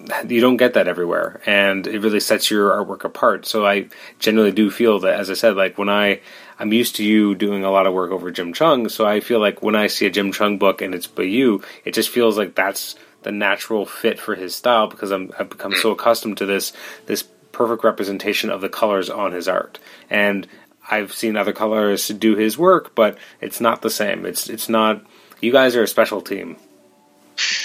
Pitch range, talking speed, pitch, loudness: 100-110 Hz, 220 wpm, 105 Hz, -18 LUFS